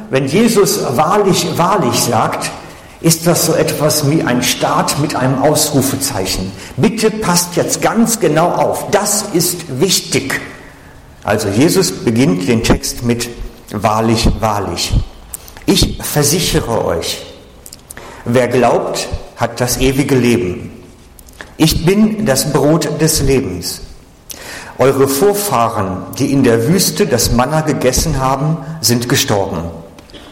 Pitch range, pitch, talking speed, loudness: 110-160 Hz, 135 Hz, 115 wpm, -13 LUFS